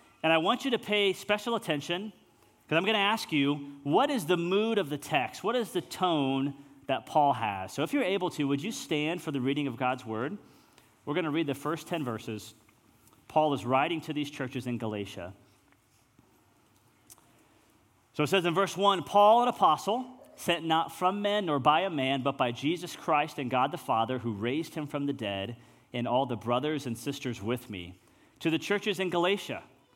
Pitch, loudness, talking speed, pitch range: 145 Hz, -29 LUFS, 205 wpm, 125-180 Hz